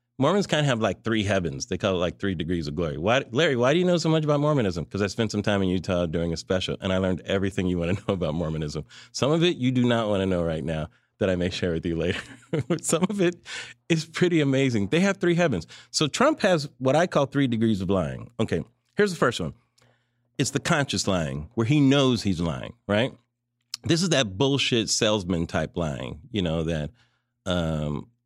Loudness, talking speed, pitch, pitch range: -25 LUFS, 230 wpm, 115 Hz, 90-140 Hz